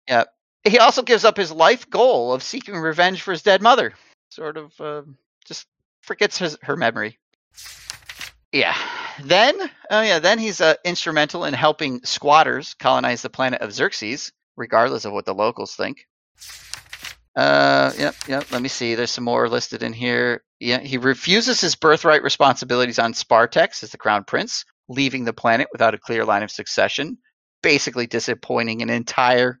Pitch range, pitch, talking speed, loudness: 125-180 Hz, 140 Hz, 170 wpm, -19 LUFS